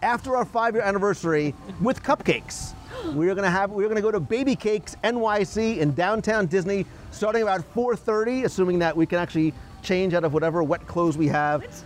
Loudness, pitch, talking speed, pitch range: -24 LUFS, 195 Hz, 165 wpm, 165-220 Hz